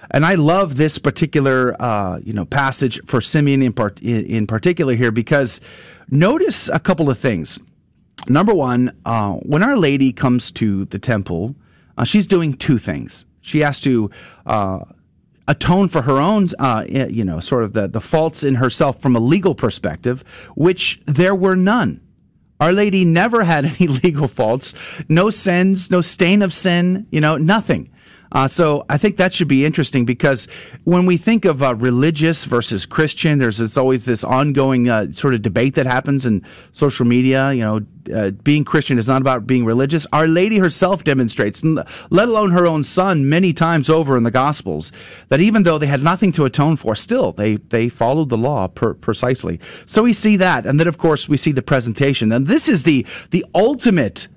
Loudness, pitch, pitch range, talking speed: -16 LUFS, 140 Hz, 120-170 Hz, 190 wpm